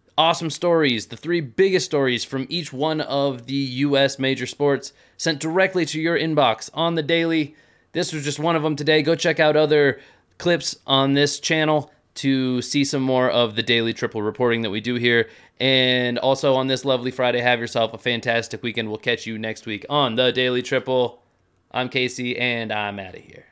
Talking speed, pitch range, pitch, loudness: 195 wpm, 120-155 Hz, 135 Hz, -21 LUFS